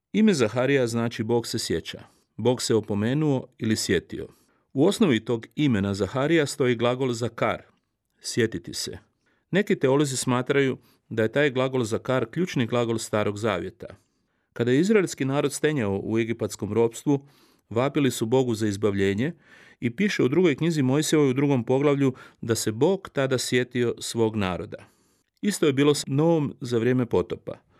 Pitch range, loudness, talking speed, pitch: 115-145 Hz, -24 LUFS, 155 wpm, 125 Hz